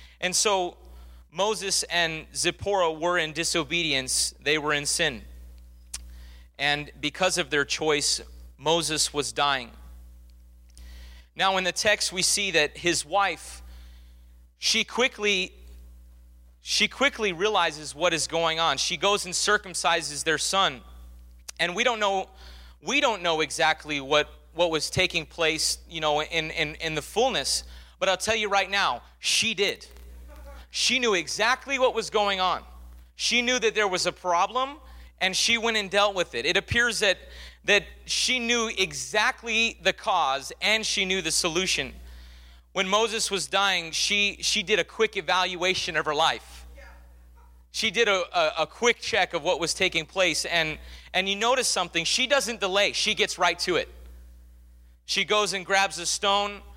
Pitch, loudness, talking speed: 170 Hz, -24 LUFS, 160 wpm